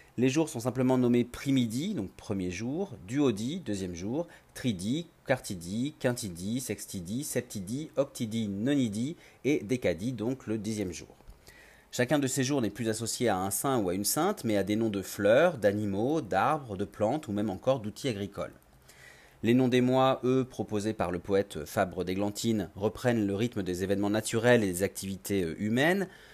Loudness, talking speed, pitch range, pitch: -30 LUFS, 170 wpm, 100-130 Hz, 110 Hz